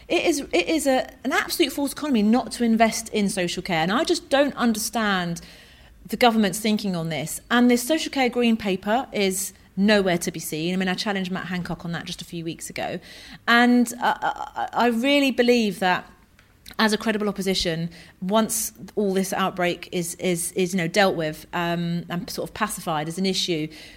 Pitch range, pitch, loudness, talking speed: 175-240 Hz, 200 Hz, -23 LUFS, 200 wpm